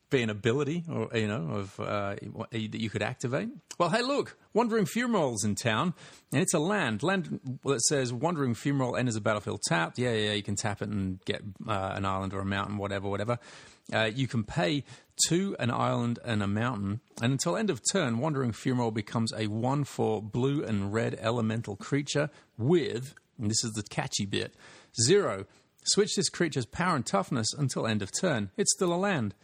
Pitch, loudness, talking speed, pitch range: 120 Hz, -30 LUFS, 200 wpm, 105-145 Hz